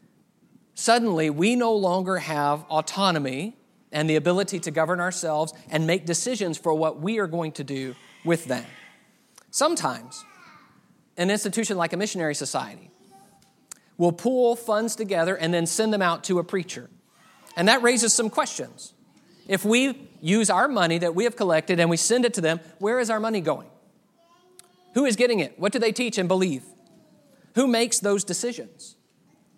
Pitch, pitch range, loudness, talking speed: 195 Hz, 165-230 Hz, -24 LUFS, 165 wpm